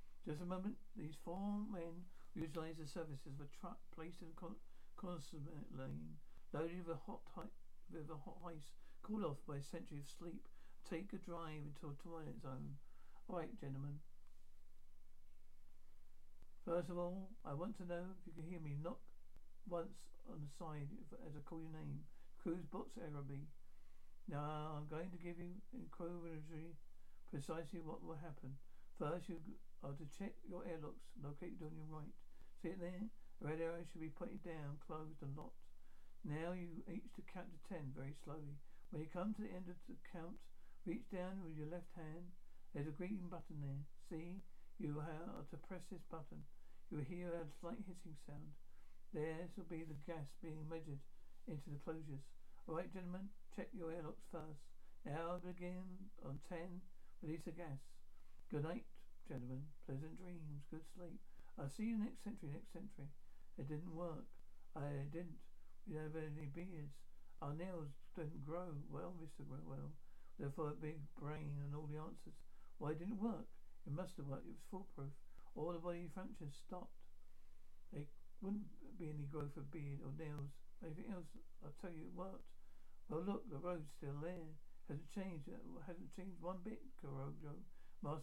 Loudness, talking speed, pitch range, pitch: -51 LUFS, 175 wpm, 140-175 Hz, 155 Hz